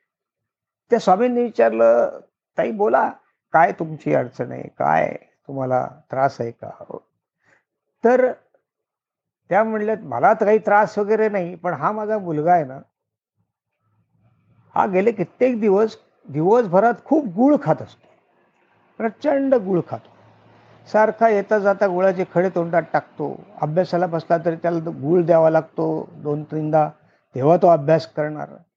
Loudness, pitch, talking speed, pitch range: -19 LUFS, 175 Hz, 130 wpm, 150-215 Hz